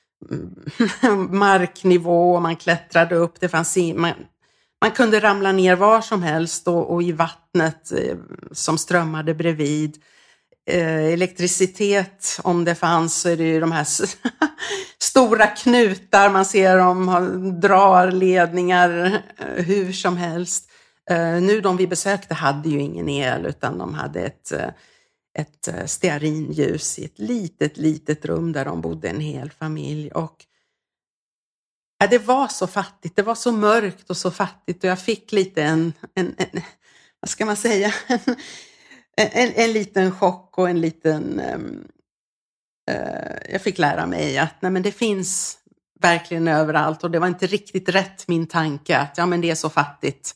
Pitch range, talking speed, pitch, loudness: 165-200 Hz, 155 wpm, 180 Hz, -20 LUFS